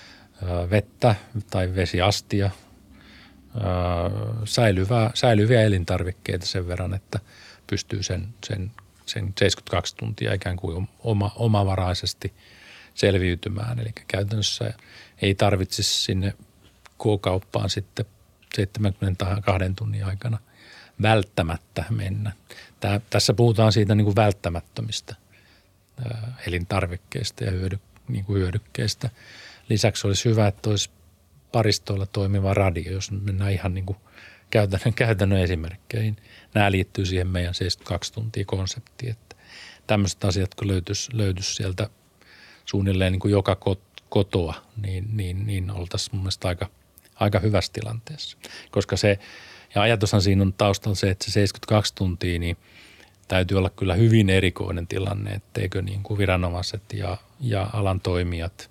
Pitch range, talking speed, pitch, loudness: 95-110 Hz, 120 wpm, 100 Hz, -24 LUFS